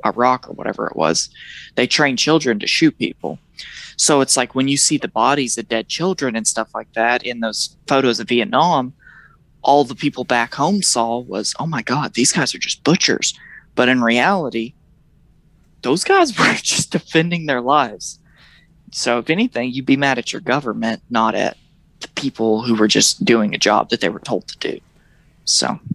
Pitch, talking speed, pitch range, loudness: 125 Hz, 190 wpm, 115-145 Hz, -17 LUFS